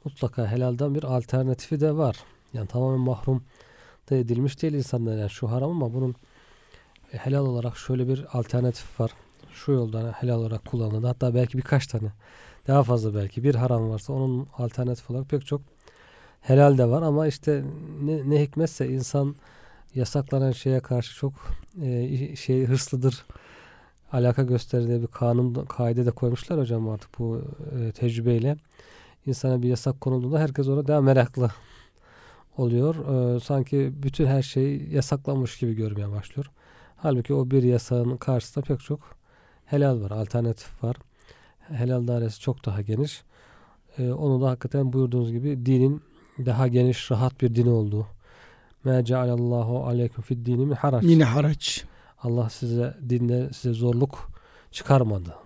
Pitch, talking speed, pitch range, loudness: 125 Hz, 145 wpm, 120-140 Hz, -25 LUFS